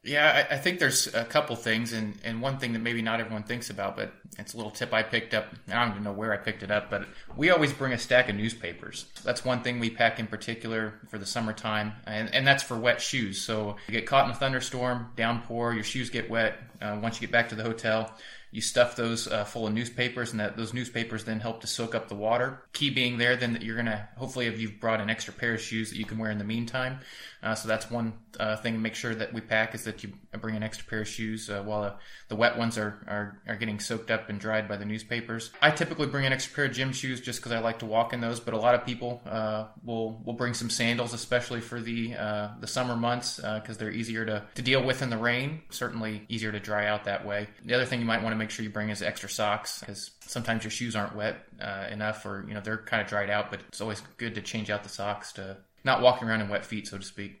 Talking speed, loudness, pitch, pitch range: 270 wpm, -29 LUFS, 115 Hz, 105-120 Hz